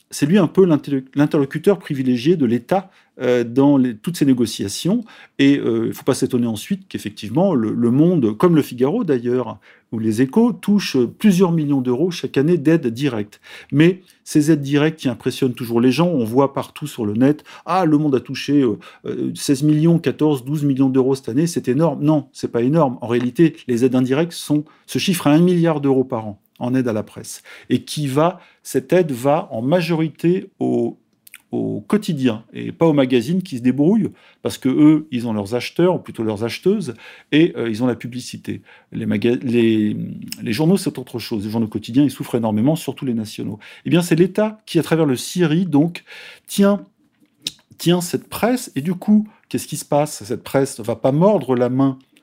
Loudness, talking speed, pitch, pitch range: -18 LUFS, 200 wpm, 140 Hz, 125-165 Hz